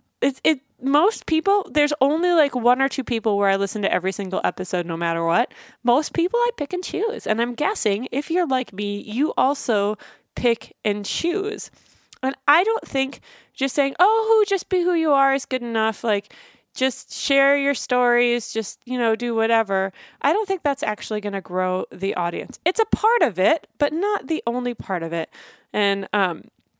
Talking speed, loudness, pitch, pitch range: 200 wpm, -22 LUFS, 255 Hz, 210-305 Hz